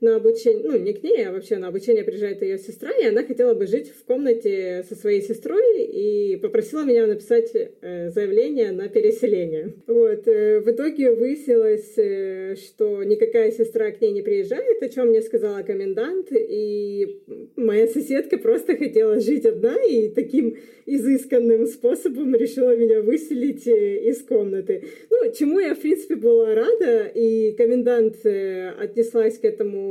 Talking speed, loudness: 150 wpm, -21 LUFS